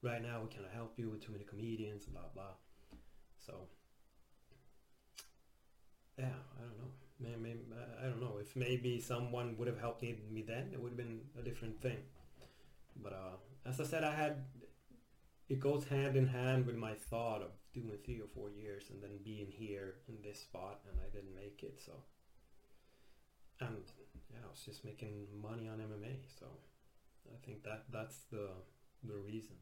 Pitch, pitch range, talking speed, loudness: 115 Hz, 105-130 Hz, 180 wpm, -45 LUFS